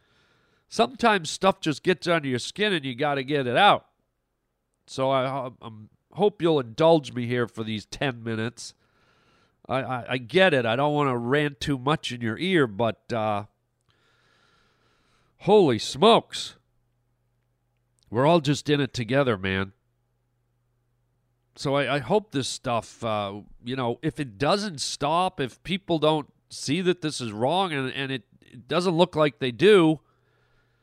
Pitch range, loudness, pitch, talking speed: 120-155 Hz, -24 LUFS, 130 Hz, 160 wpm